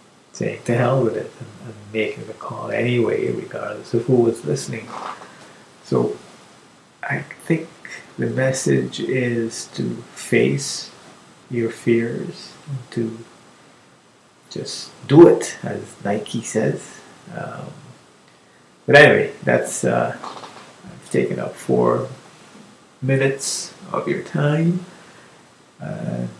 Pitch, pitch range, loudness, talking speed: 120 Hz, 110-145 Hz, -20 LUFS, 105 wpm